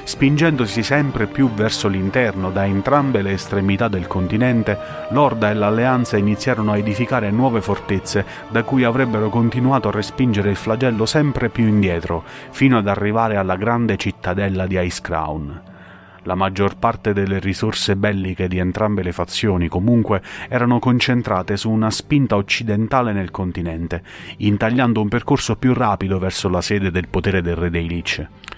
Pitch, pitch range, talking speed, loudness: 105 Hz, 95-120 Hz, 150 wpm, -19 LUFS